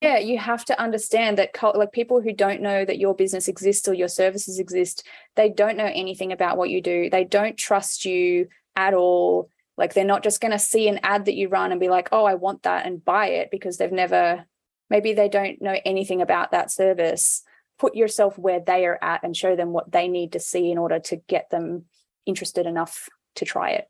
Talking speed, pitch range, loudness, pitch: 230 wpm, 180-210 Hz, -22 LUFS, 195 Hz